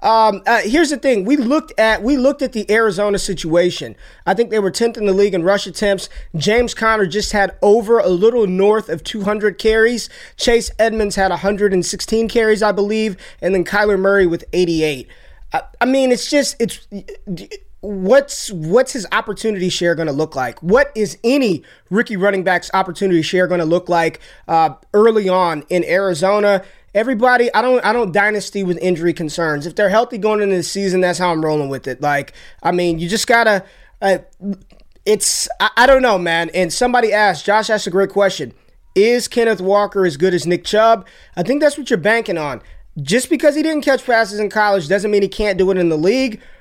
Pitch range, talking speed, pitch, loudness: 180-225 Hz, 200 wpm, 205 Hz, -16 LUFS